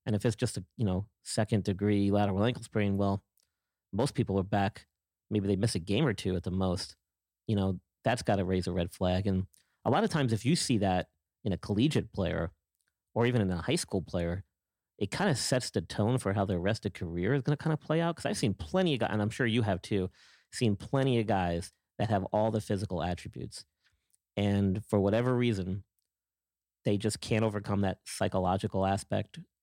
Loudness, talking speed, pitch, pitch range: -31 LUFS, 220 wpm, 100 Hz, 95-110 Hz